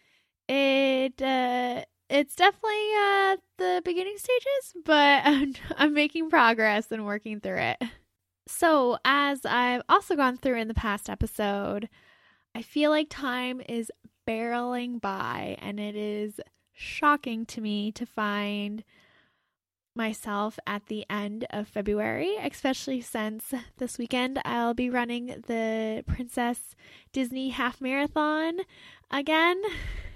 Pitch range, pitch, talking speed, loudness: 220-295 Hz, 250 Hz, 125 wpm, -27 LUFS